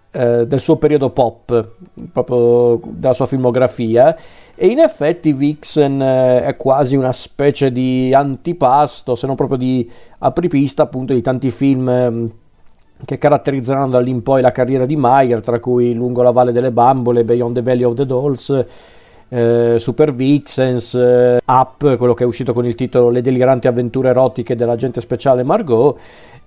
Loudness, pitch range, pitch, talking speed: -14 LUFS, 125-135 Hz, 130 Hz, 145 wpm